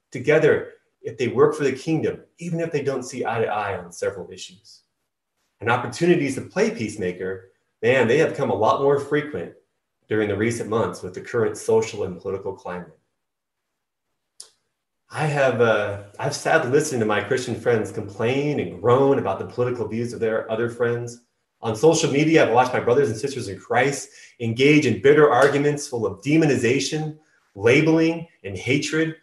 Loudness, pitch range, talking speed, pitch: -21 LUFS, 120-160 Hz, 170 wpm, 140 Hz